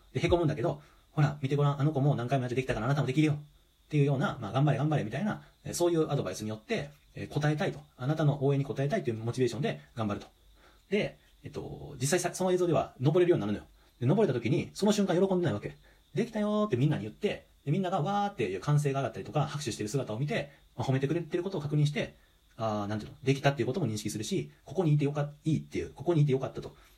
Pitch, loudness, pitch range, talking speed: 145 Hz, -31 LUFS, 125-165 Hz, 520 characters per minute